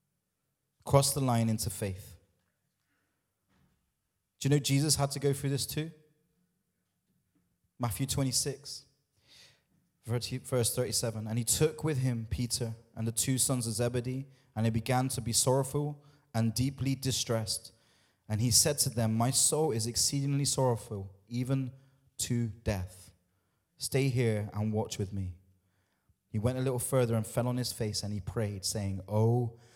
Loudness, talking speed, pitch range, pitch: -31 LUFS, 150 wpm, 110-135 Hz, 120 Hz